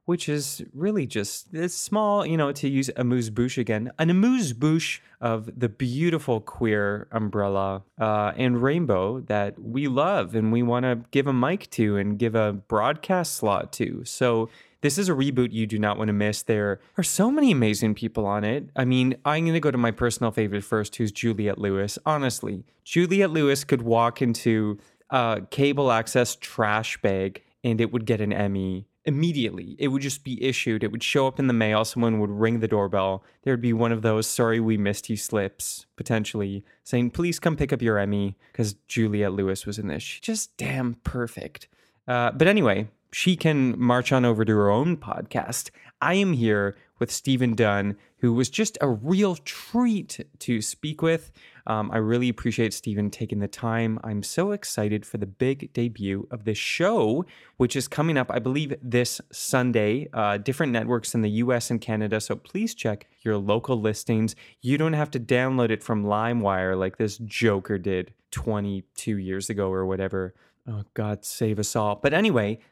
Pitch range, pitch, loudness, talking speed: 105-135 Hz, 115 Hz, -25 LUFS, 190 wpm